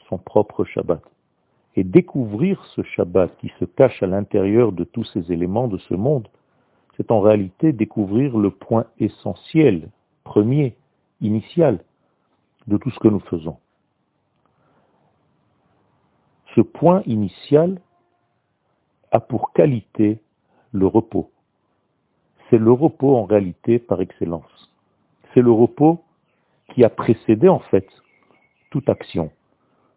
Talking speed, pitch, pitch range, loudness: 120 wpm, 115 Hz, 100-135 Hz, -19 LUFS